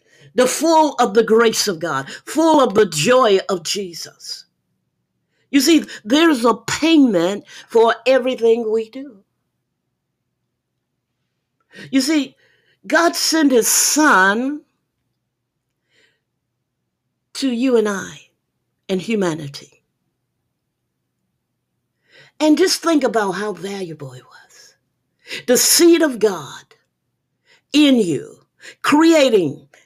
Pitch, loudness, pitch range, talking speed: 245 Hz, -16 LUFS, 205-300 Hz, 100 wpm